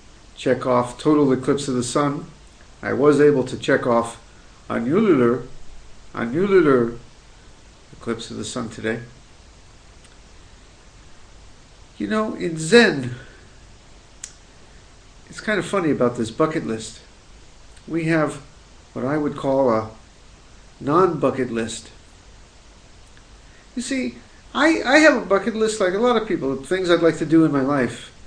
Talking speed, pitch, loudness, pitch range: 130 wpm, 130 Hz, -20 LUFS, 110-160 Hz